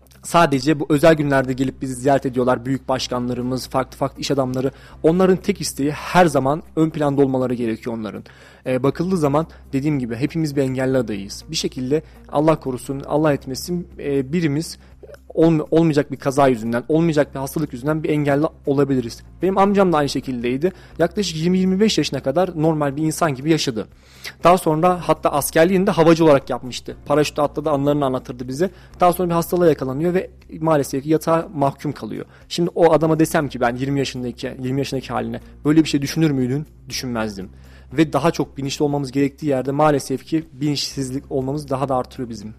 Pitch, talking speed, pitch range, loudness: 145 Hz, 170 wpm, 130-160 Hz, -20 LUFS